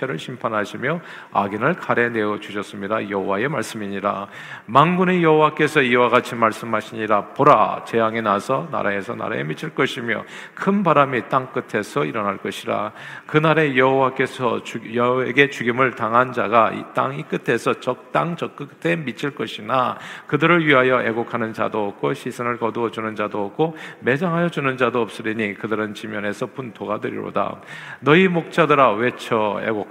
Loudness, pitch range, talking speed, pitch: -20 LUFS, 110-140 Hz, 340 characters per minute, 120 Hz